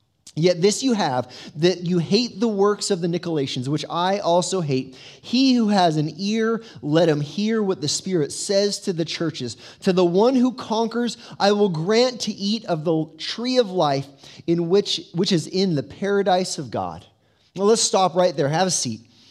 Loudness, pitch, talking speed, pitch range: -21 LUFS, 180 Hz, 195 wpm, 150-205 Hz